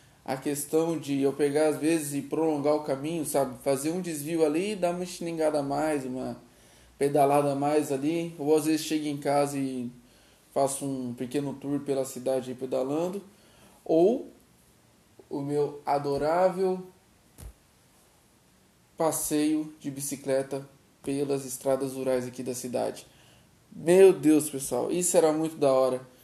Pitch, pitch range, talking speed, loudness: 145 Hz, 135-155 Hz, 140 wpm, -27 LUFS